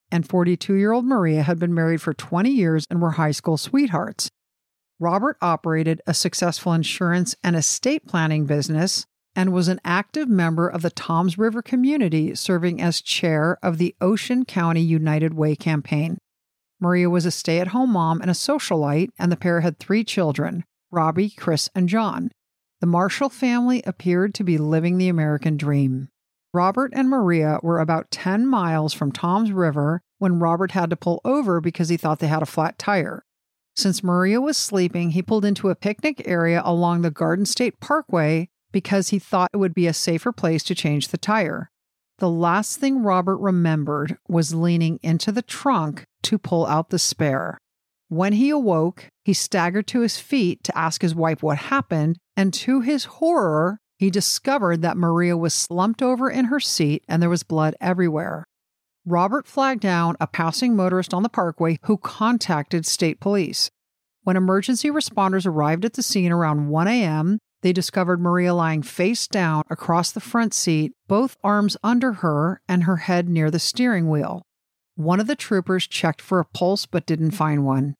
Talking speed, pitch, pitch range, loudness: 180 wpm, 175 Hz, 165-205 Hz, -21 LUFS